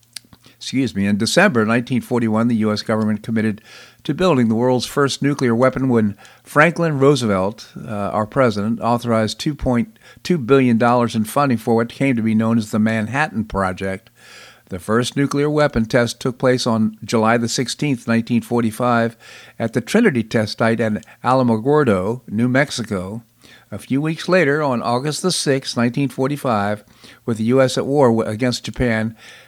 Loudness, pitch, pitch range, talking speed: -18 LUFS, 120 Hz, 110-130 Hz, 145 wpm